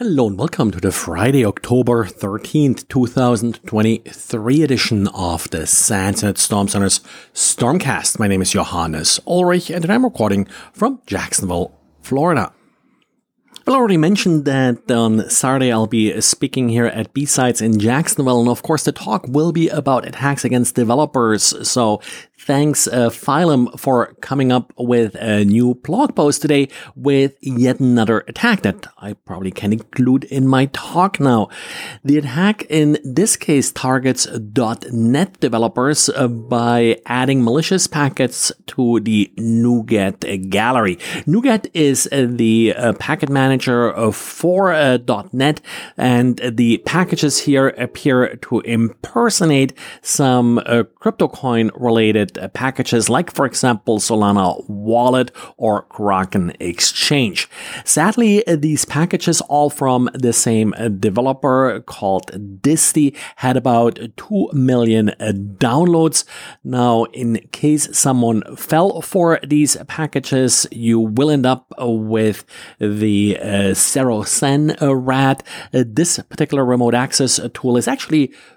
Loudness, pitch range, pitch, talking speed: -16 LUFS, 115-145 Hz, 125 Hz, 120 wpm